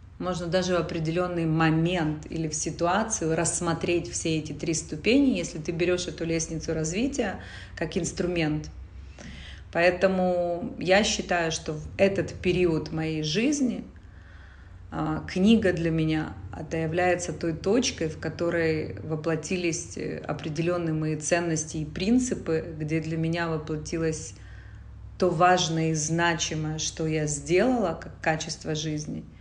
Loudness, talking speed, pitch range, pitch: -27 LUFS, 120 wpm, 155-175 Hz, 165 Hz